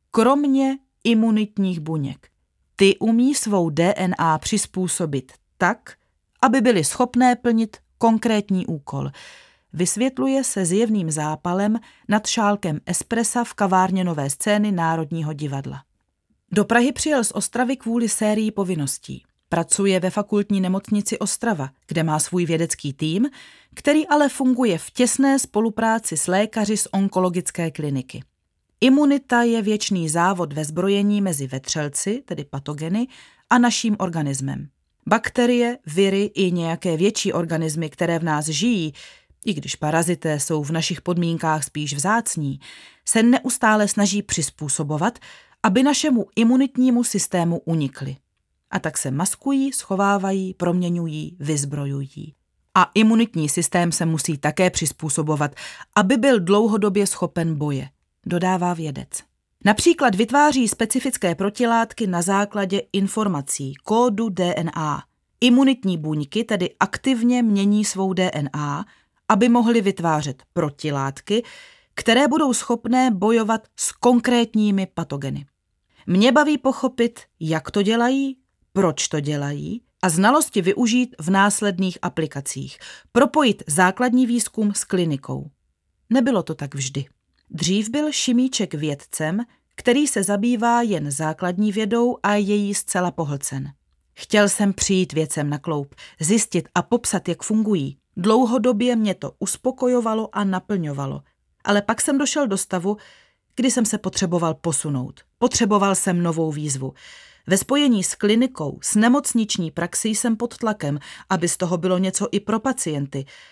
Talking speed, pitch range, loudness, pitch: 125 wpm, 160-230 Hz, -21 LUFS, 195 Hz